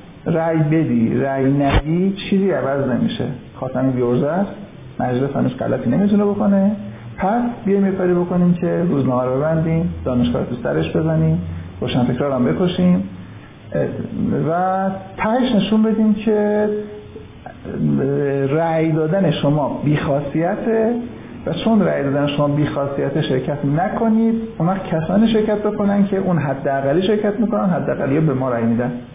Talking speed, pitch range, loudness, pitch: 125 wpm, 135-200 Hz, -18 LUFS, 160 Hz